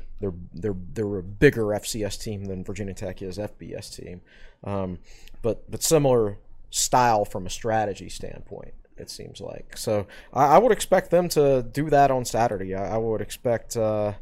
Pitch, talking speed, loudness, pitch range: 105 Hz, 175 wpm, -24 LUFS, 100-115 Hz